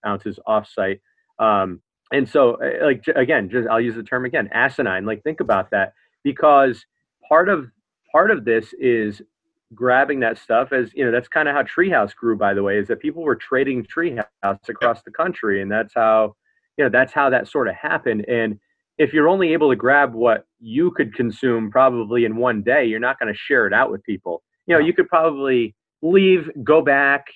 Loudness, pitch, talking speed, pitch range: -19 LUFS, 125 Hz, 205 wpm, 115-165 Hz